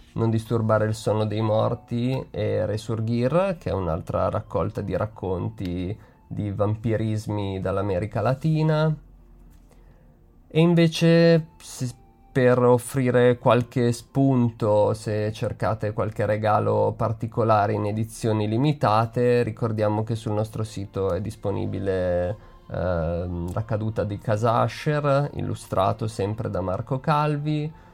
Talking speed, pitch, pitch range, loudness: 105 wpm, 110 Hz, 105-125 Hz, -24 LUFS